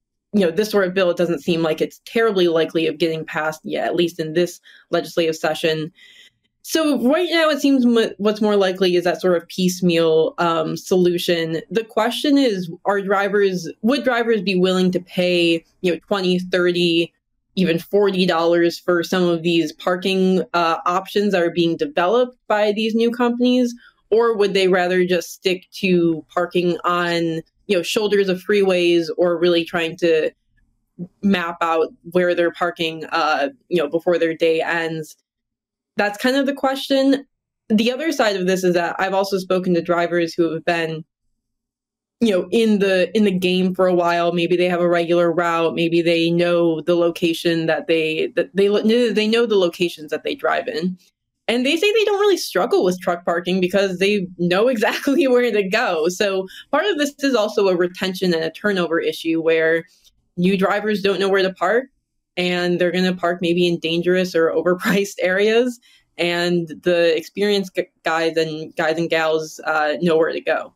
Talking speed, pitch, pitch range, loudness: 180 wpm, 180 Hz, 170-205 Hz, -19 LUFS